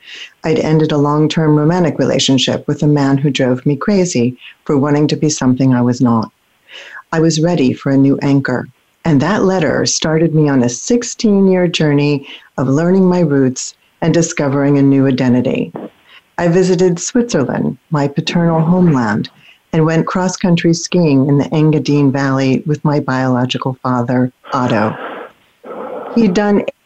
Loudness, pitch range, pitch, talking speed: -13 LUFS, 135-170 Hz, 150 Hz, 150 wpm